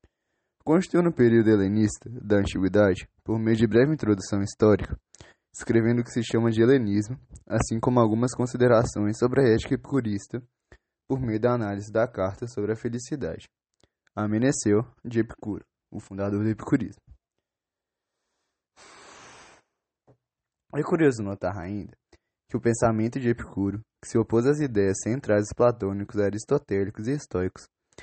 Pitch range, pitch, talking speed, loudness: 105-125 Hz, 115 Hz, 135 wpm, -25 LUFS